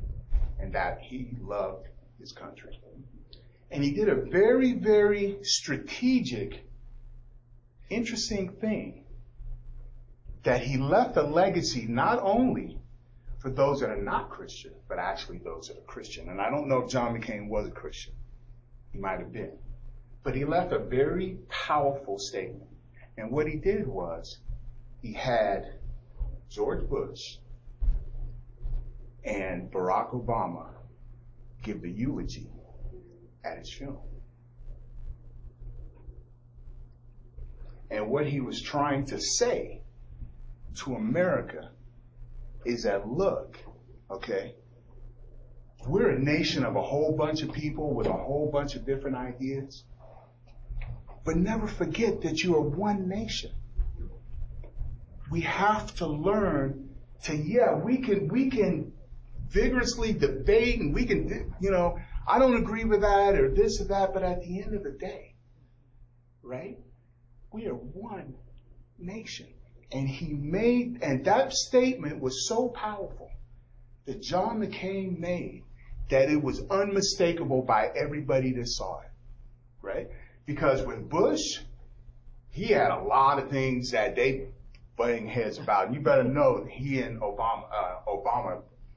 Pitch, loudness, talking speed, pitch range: 125 Hz, -29 LUFS, 130 wpm, 115-160 Hz